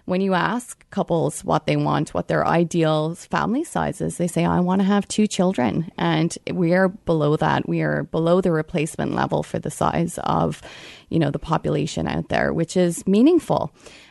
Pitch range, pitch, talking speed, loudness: 165-190 Hz, 175 Hz, 185 wpm, -21 LUFS